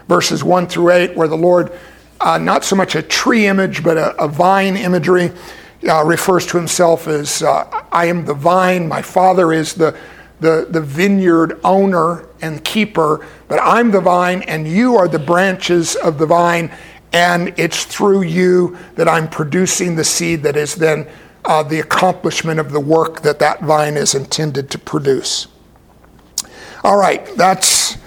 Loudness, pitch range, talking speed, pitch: -14 LUFS, 160-185 Hz, 170 wpm, 170 Hz